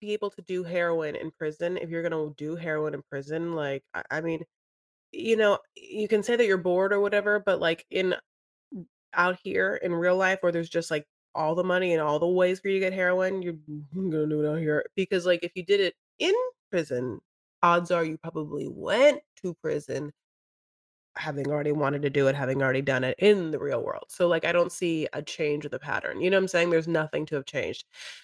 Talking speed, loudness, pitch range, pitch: 225 wpm, -27 LUFS, 150-190 Hz, 170 Hz